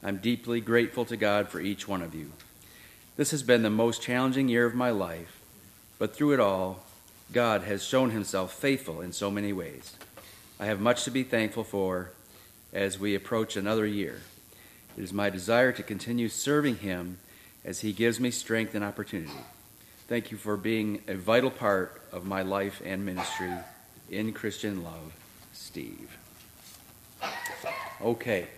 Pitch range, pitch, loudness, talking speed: 95-115 Hz, 105 Hz, -29 LUFS, 160 wpm